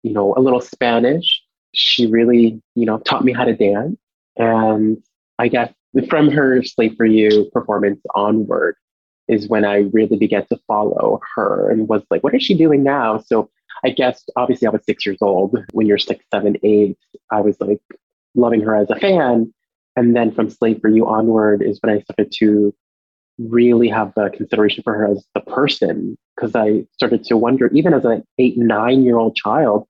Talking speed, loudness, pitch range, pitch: 195 wpm, -16 LUFS, 105-120 Hz, 110 Hz